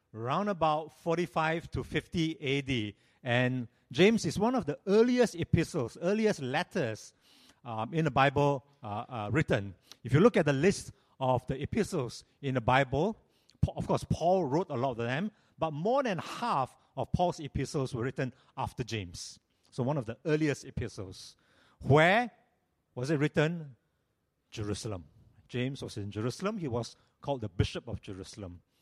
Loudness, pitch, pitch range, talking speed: -31 LUFS, 140 Hz, 120-165 Hz, 160 wpm